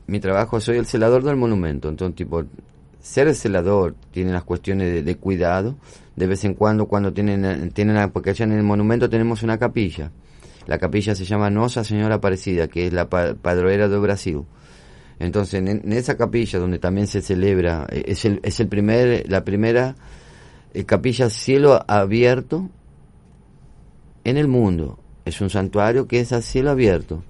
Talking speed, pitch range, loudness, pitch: 170 wpm, 90-115 Hz, -20 LUFS, 100 Hz